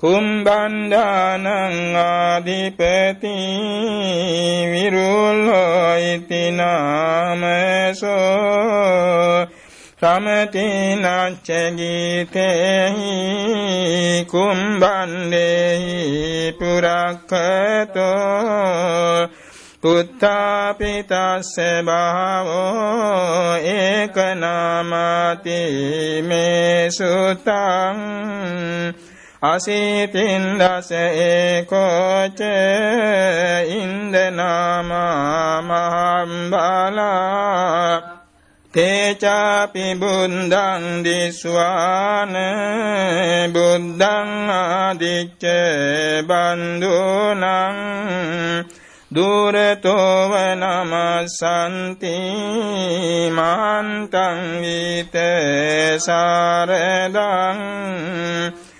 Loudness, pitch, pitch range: -18 LUFS, 180 Hz, 170-195 Hz